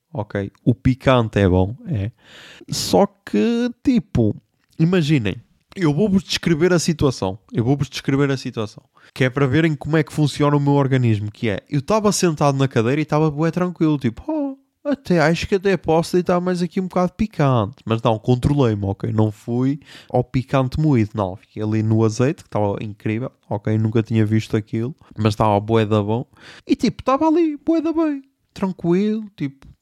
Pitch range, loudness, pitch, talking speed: 115-180 Hz, -20 LUFS, 140 Hz, 185 wpm